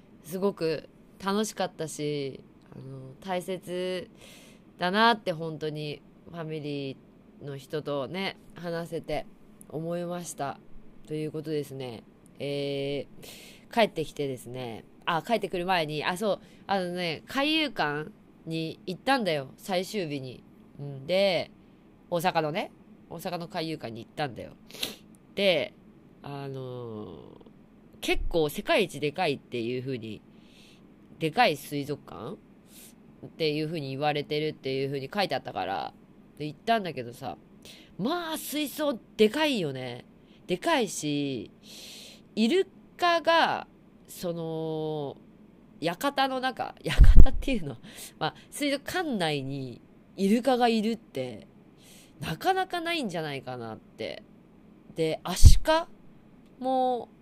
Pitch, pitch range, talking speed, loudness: 170 Hz, 145-215 Hz, 230 characters per minute, -29 LUFS